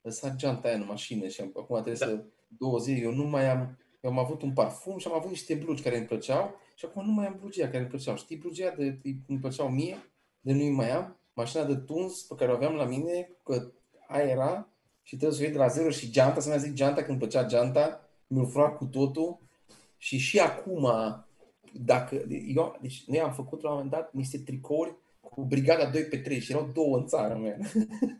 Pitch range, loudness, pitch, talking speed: 130-155 Hz, -30 LUFS, 140 Hz, 225 wpm